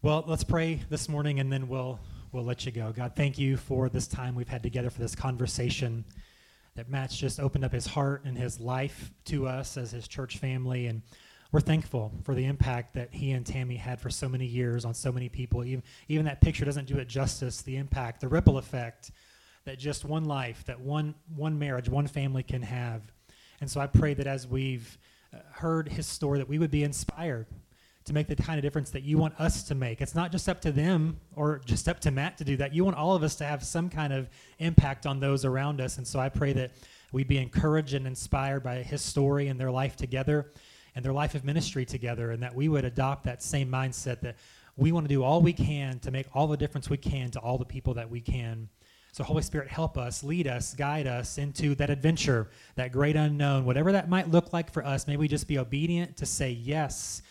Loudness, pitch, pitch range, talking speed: -30 LUFS, 135 Hz, 125-150 Hz, 235 wpm